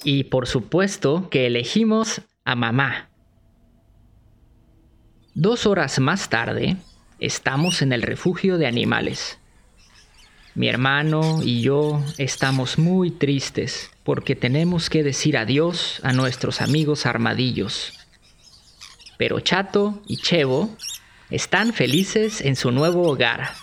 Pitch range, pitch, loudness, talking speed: 120-165 Hz, 140 Hz, -21 LUFS, 110 wpm